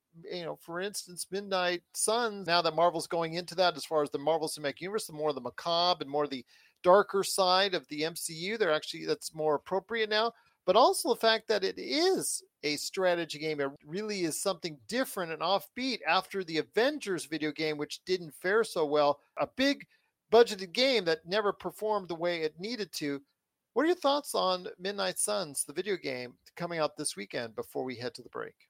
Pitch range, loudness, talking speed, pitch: 155-210 Hz, -31 LUFS, 205 wpm, 175 Hz